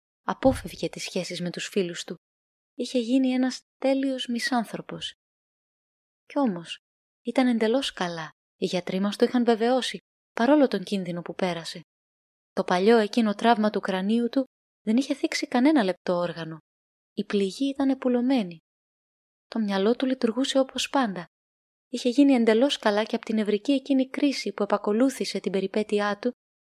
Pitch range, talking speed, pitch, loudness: 190-260 Hz, 150 wpm, 225 Hz, -25 LUFS